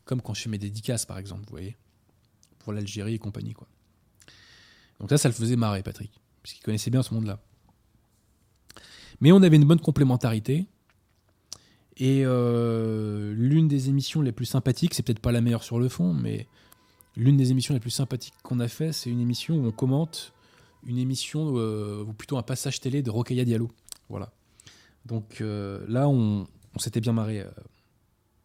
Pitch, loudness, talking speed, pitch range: 115 Hz, -25 LUFS, 185 wpm, 105-130 Hz